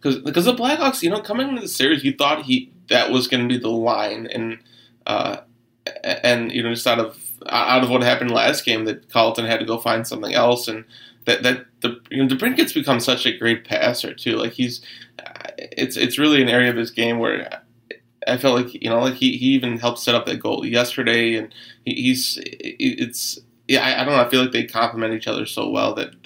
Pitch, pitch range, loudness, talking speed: 120 Hz, 115-150 Hz, -19 LUFS, 230 wpm